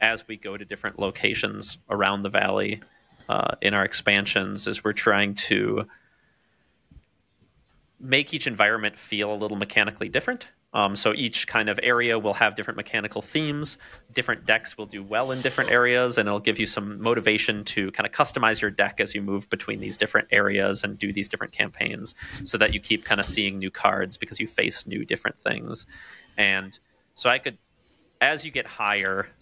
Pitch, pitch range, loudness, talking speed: 105 Hz, 100-115 Hz, -24 LUFS, 185 wpm